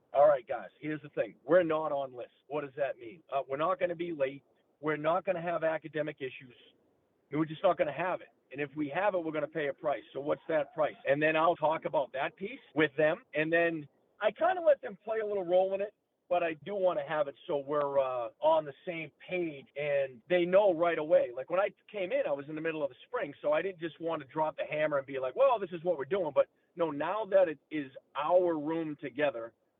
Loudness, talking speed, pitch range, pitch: -32 LUFS, 270 wpm, 145-185 Hz, 160 Hz